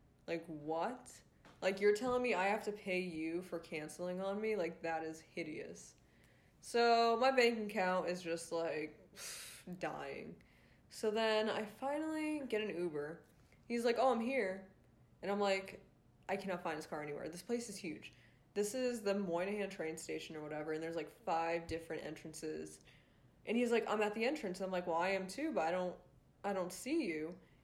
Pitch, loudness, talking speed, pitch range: 185 Hz, -39 LUFS, 190 wpm, 160-215 Hz